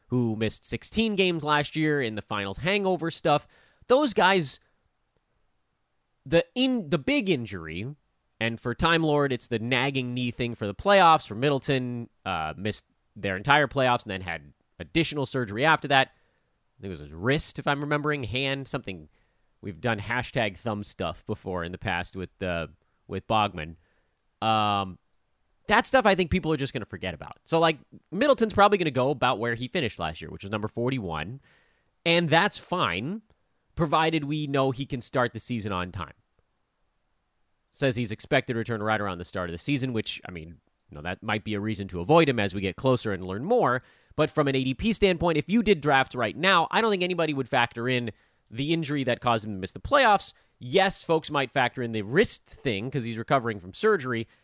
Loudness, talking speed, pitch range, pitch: -26 LUFS, 200 wpm, 105-155 Hz, 125 Hz